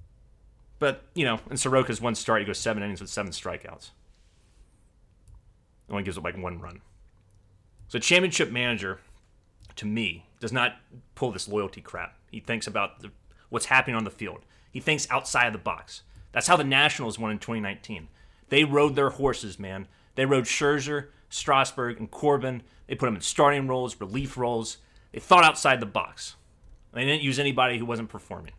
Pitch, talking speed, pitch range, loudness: 110 Hz, 175 wpm, 100-130 Hz, -25 LUFS